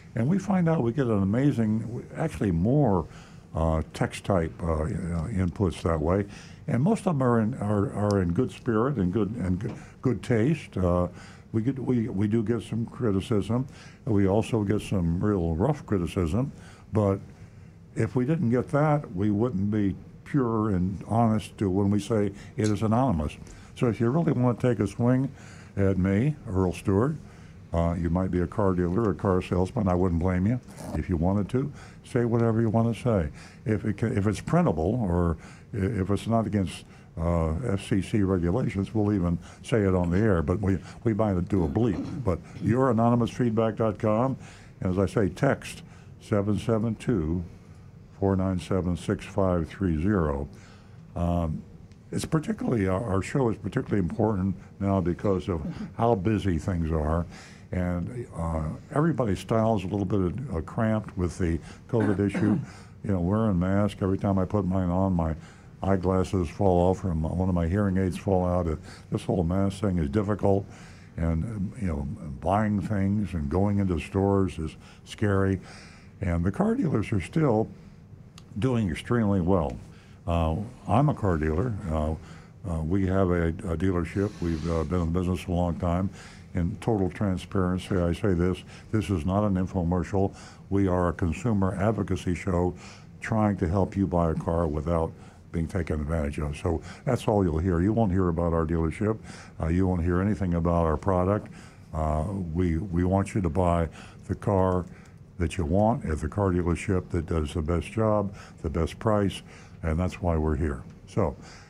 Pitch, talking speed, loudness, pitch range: 95 Hz, 180 wpm, -27 LUFS, 90-110 Hz